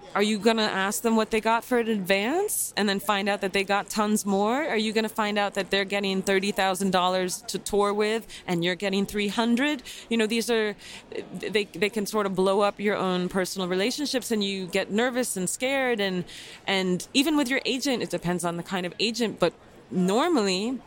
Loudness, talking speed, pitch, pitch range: -25 LUFS, 215 wpm, 205 Hz, 195-225 Hz